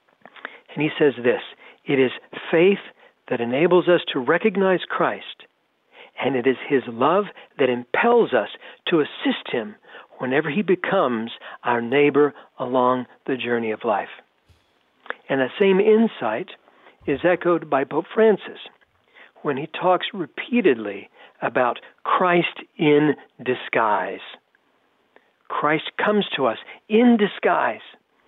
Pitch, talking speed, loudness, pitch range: 150 Hz, 120 wpm, -21 LUFS, 130-200 Hz